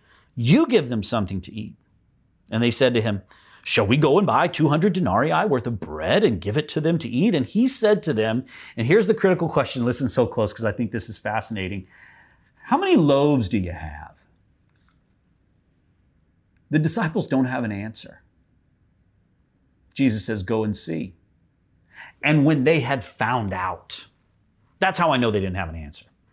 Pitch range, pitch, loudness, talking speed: 95-145 Hz, 115 Hz, -21 LUFS, 180 wpm